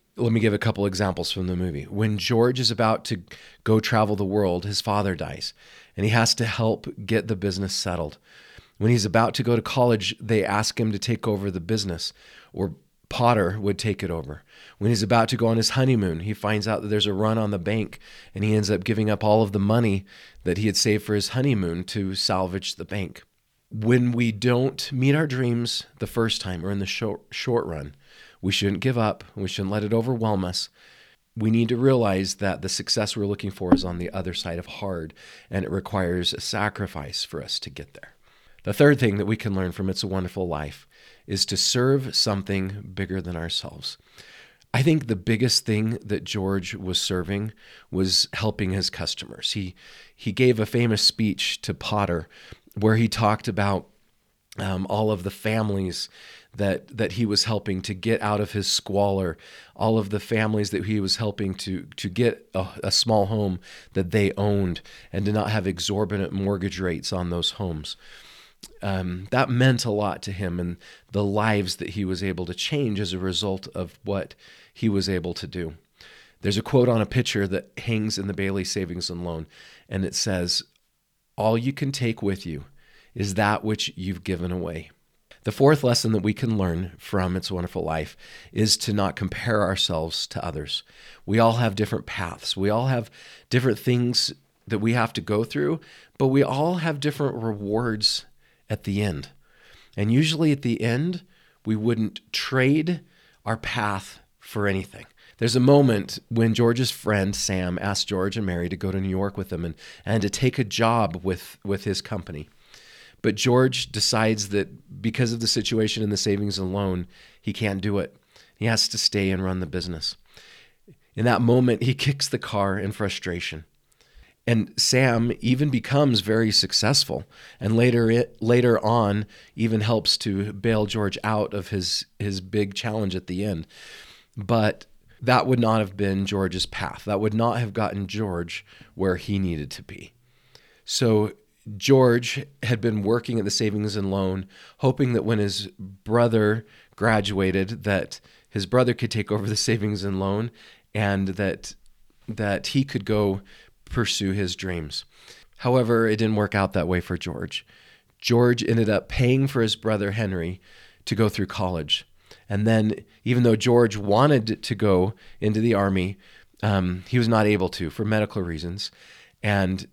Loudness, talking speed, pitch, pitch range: -24 LUFS, 185 wpm, 105 Hz, 95-115 Hz